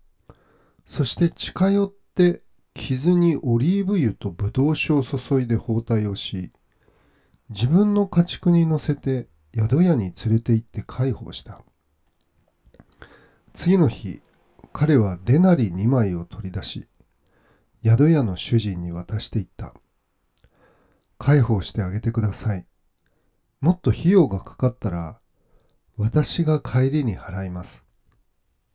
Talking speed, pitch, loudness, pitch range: 220 characters per minute, 115 Hz, -22 LUFS, 95-150 Hz